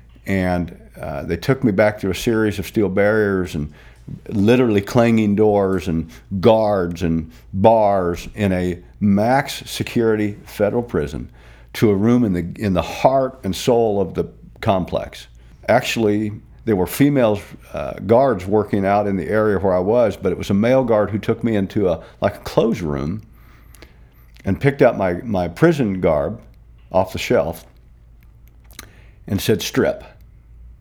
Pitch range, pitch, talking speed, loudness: 85-110 Hz, 100 Hz, 155 wpm, -19 LUFS